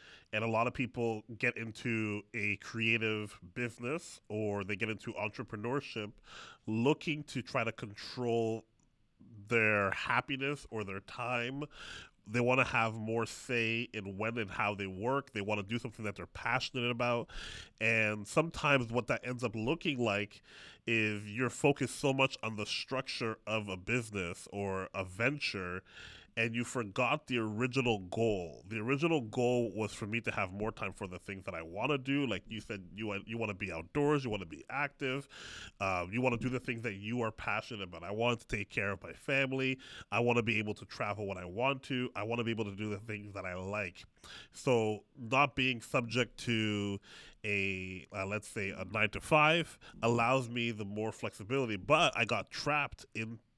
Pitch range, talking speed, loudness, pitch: 105-125 Hz, 195 wpm, -35 LUFS, 115 Hz